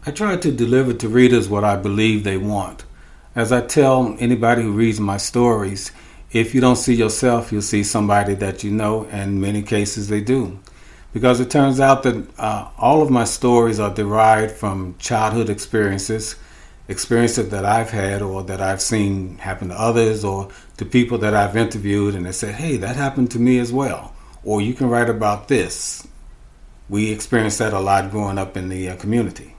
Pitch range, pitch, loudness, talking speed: 100-120 Hz, 110 Hz, -18 LUFS, 195 wpm